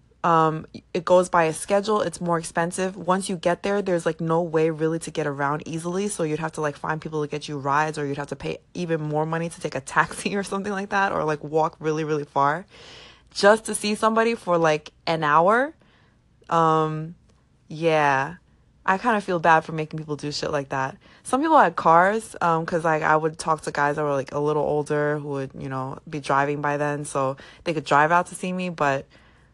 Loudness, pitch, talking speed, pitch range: -23 LUFS, 160 Hz, 230 wpm, 150-180 Hz